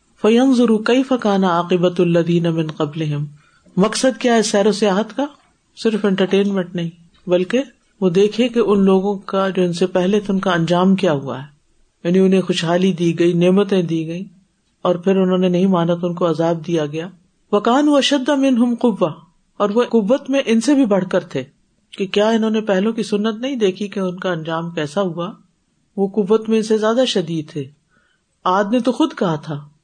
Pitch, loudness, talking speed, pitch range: 195 Hz, -17 LUFS, 195 wpm, 175-220 Hz